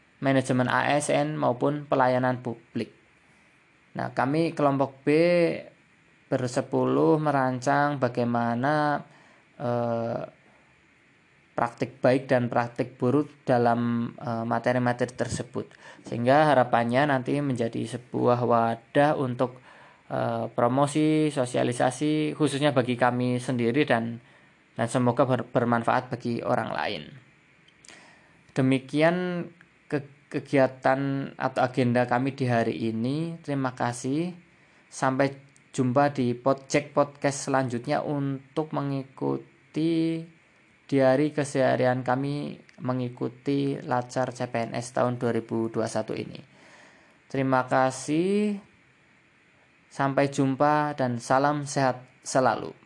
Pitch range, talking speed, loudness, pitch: 120-145 Hz, 90 wpm, -26 LUFS, 130 Hz